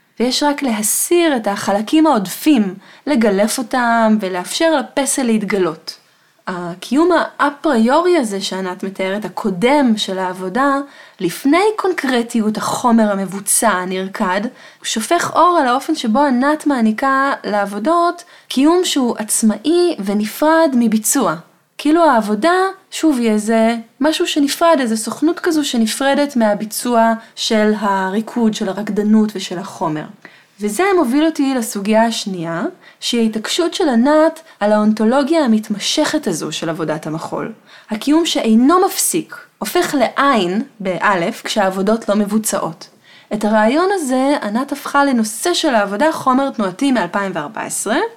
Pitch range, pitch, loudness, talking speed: 205-295 Hz, 230 Hz, -16 LUFS, 115 wpm